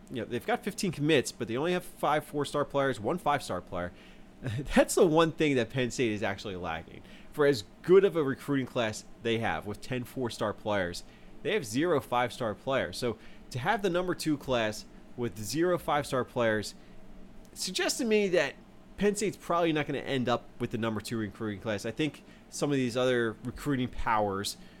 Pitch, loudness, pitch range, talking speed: 125 Hz, -30 LUFS, 115-155 Hz, 195 wpm